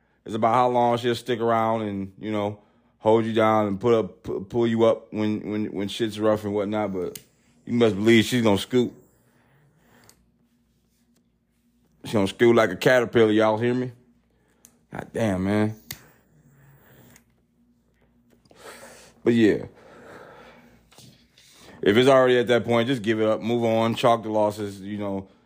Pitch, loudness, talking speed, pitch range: 110 Hz, -22 LUFS, 150 wpm, 100-120 Hz